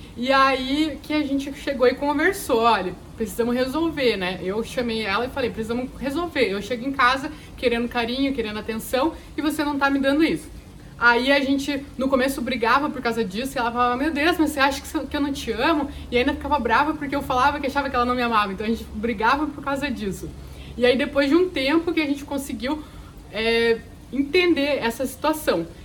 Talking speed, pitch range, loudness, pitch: 210 wpm, 235-290 Hz, -22 LUFS, 270 Hz